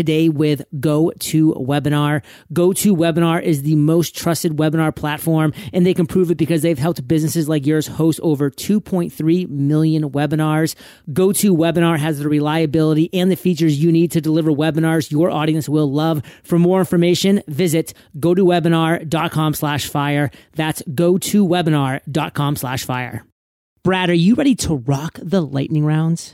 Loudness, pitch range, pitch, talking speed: -17 LUFS, 150-170 Hz, 160 Hz, 140 wpm